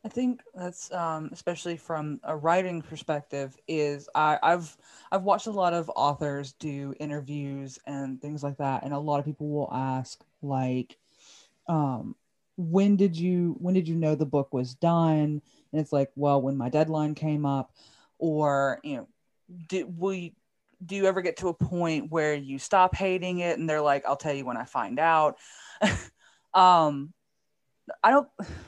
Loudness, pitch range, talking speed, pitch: -27 LUFS, 140-175 Hz, 170 wpm, 155 Hz